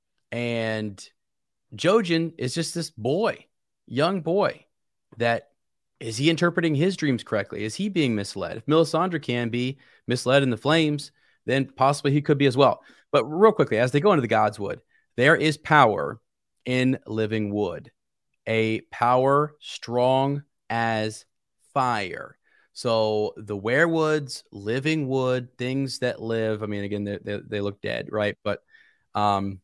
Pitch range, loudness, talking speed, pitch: 110-150 Hz, -24 LUFS, 150 wpm, 125 Hz